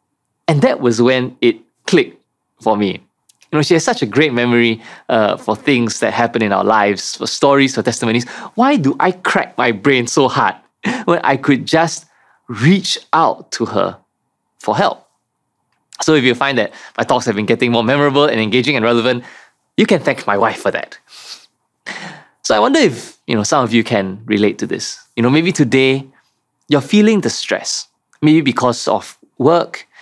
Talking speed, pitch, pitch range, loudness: 190 wpm, 125 Hz, 115-145 Hz, -15 LUFS